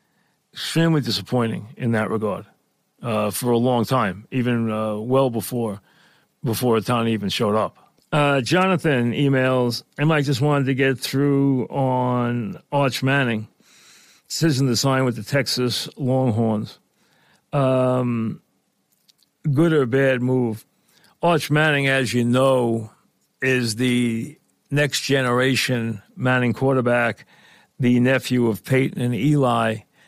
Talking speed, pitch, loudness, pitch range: 120 wpm, 125 Hz, -21 LUFS, 115-135 Hz